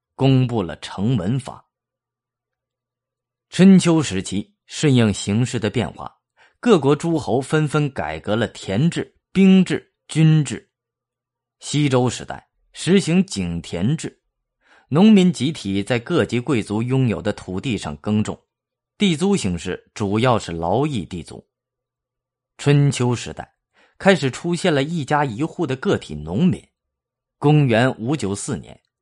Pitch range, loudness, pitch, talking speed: 105-150 Hz, -19 LUFS, 130 Hz, 190 characters per minute